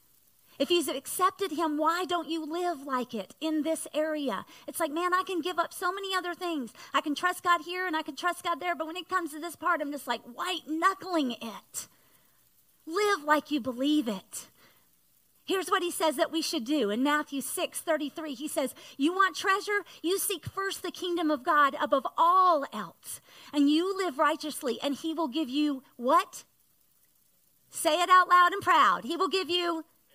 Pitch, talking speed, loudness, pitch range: 325 Hz, 200 wpm, -28 LUFS, 295-360 Hz